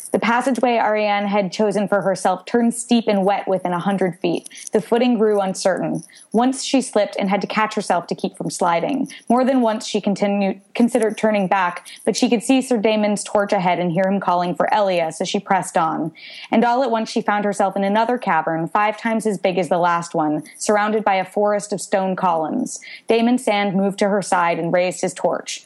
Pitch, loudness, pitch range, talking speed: 205 Hz, -19 LUFS, 190-225 Hz, 215 wpm